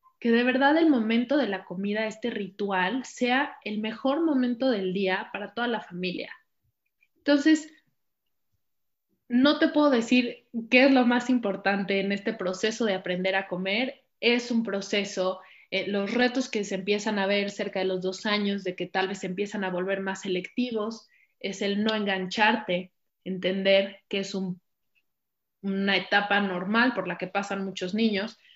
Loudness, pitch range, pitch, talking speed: -26 LUFS, 190-245 Hz, 205 Hz, 170 wpm